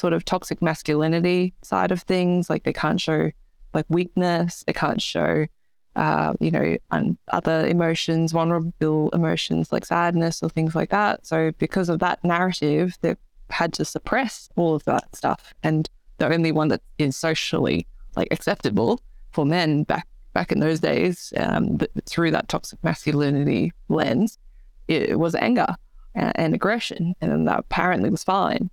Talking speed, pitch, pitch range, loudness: 165 wpm, 165 Hz, 155-180 Hz, -23 LUFS